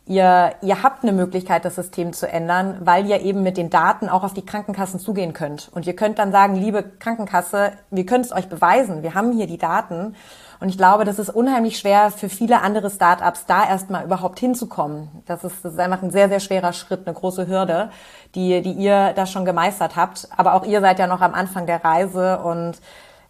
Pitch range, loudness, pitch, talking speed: 180-200 Hz, -19 LUFS, 185 Hz, 220 wpm